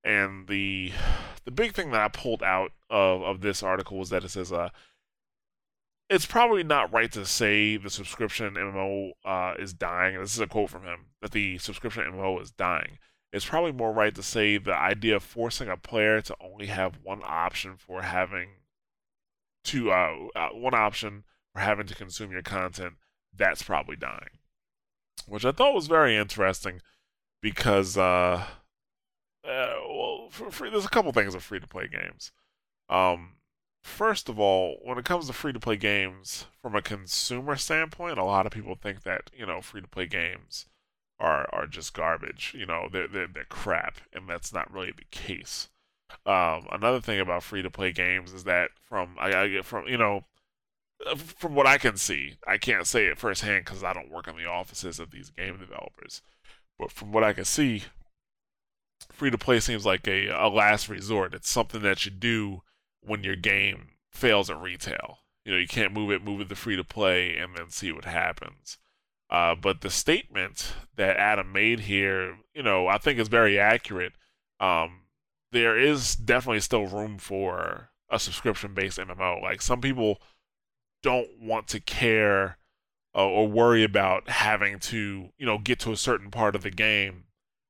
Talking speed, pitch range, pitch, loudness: 175 wpm, 95-115 Hz, 100 Hz, -27 LUFS